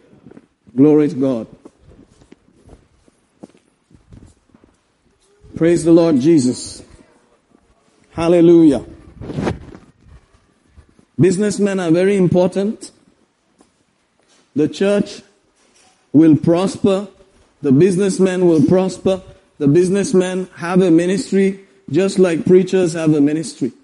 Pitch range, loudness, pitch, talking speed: 165-195 Hz, -15 LUFS, 185 Hz, 80 wpm